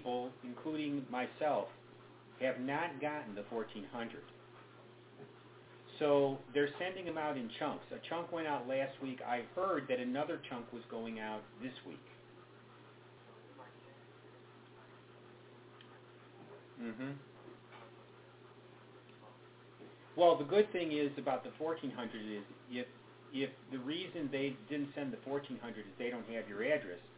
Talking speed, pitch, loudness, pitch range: 120 wpm, 130 Hz, -39 LUFS, 115-145 Hz